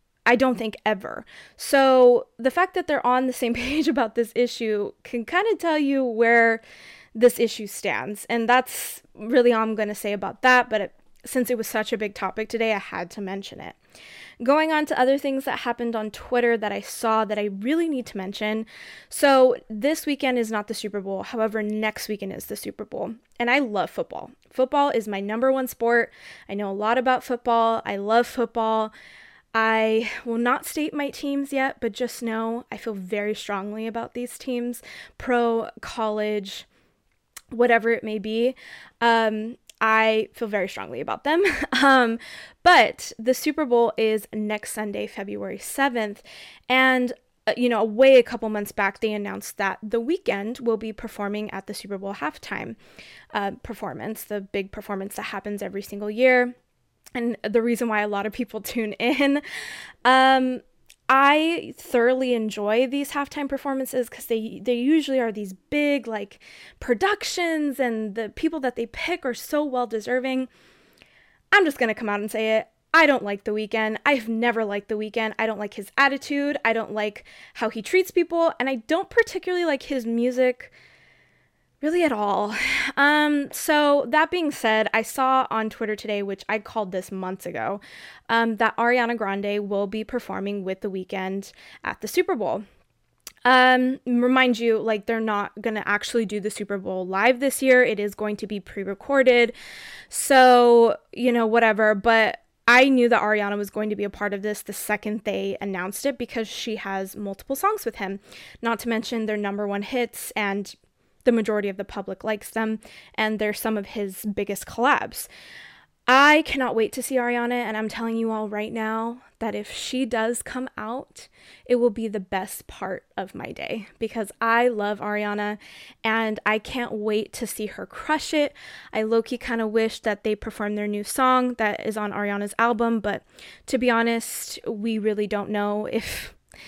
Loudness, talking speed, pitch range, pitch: -23 LUFS, 185 wpm, 210-255 Hz, 230 Hz